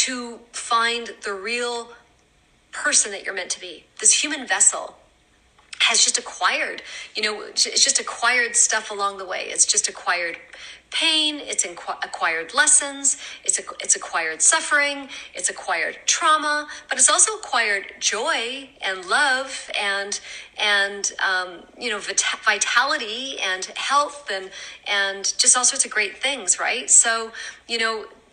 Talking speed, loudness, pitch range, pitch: 140 wpm, -20 LUFS, 200-290 Hz, 235 Hz